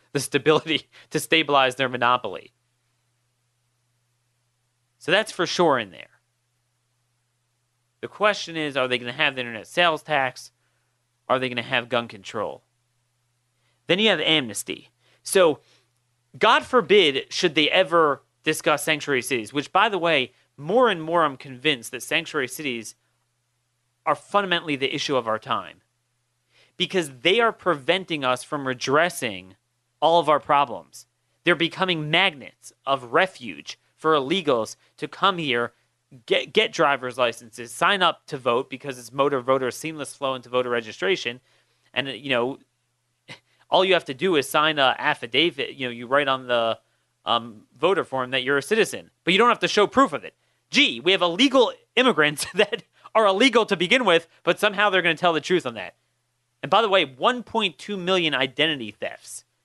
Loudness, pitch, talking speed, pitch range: -22 LUFS, 135 Hz, 165 wpm, 120-170 Hz